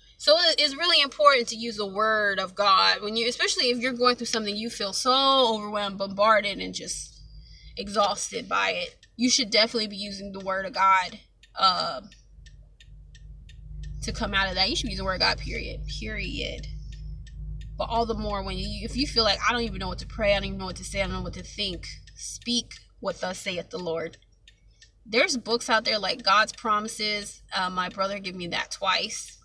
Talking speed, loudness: 210 wpm, -25 LUFS